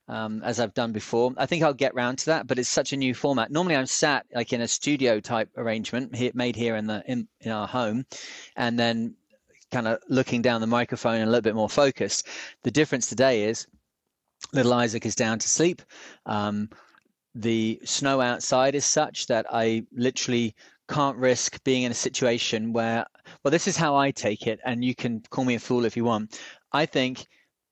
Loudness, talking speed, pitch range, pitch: -25 LUFS, 205 wpm, 115-130 Hz, 120 Hz